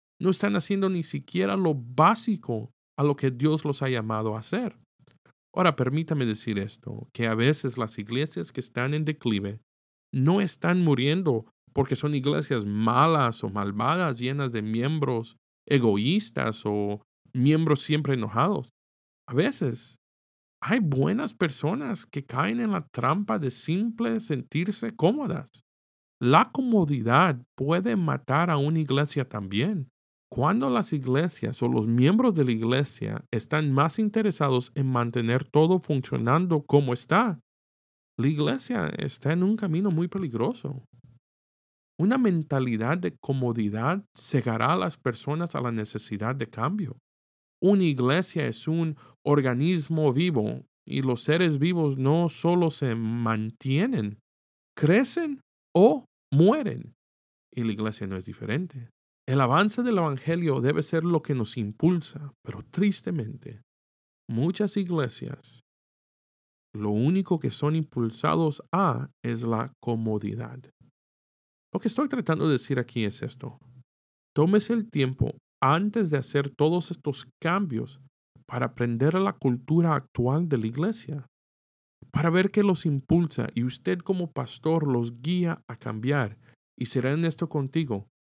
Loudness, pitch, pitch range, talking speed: -26 LUFS, 140 Hz, 120-170 Hz, 135 wpm